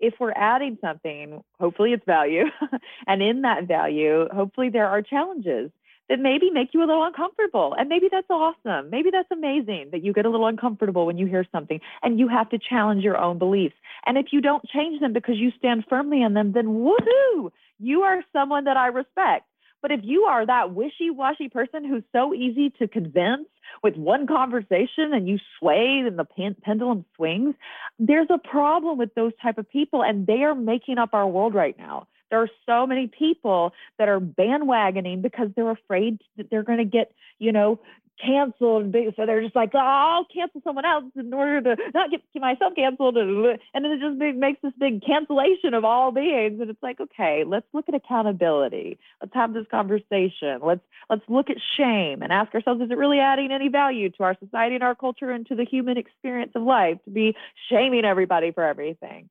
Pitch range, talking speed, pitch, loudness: 210-280 Hz, 200 wpm, 240 Hz, -23 LUFS